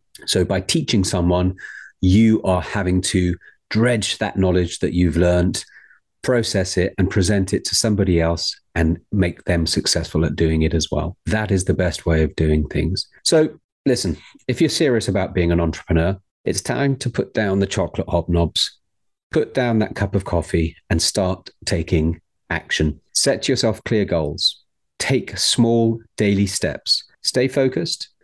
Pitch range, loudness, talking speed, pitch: 85-110 Hz, -20 LUFS, 160 wpm, 95 Hz